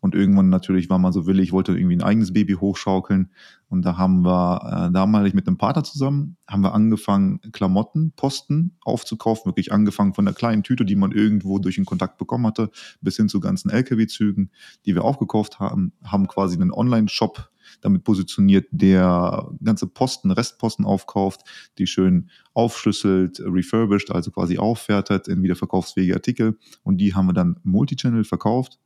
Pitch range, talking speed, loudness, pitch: 95-120 Hz, 165 wpm, -20 LUFS, 100 Hz